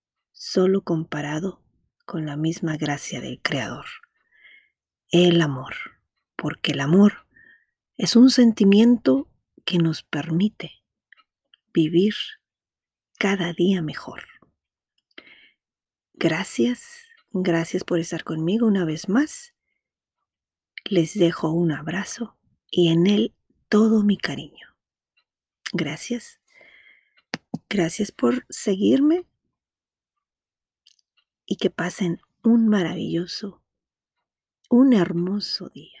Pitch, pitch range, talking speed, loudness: 185 Hz, 165-220 Hz, 90 wpm, -22 LUFS